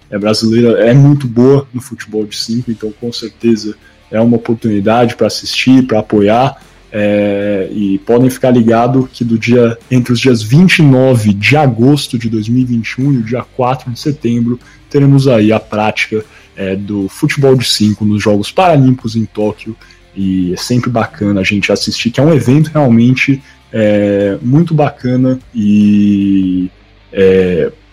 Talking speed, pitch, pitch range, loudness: 155 wpm, 115 Hz, 105-130 Hz, -11 LUFS